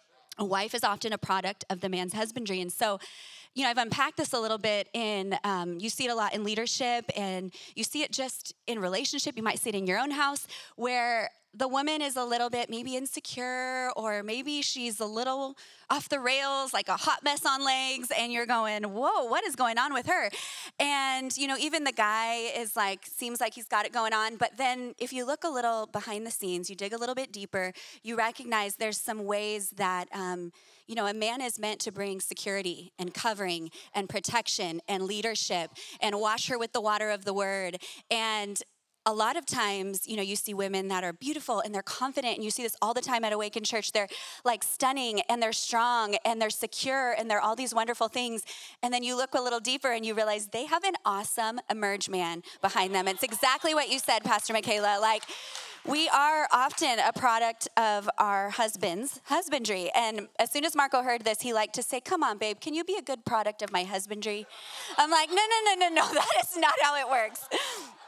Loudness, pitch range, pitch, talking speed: -29 LUFS, 205-265 Hz, 230 Hz, 220 wpm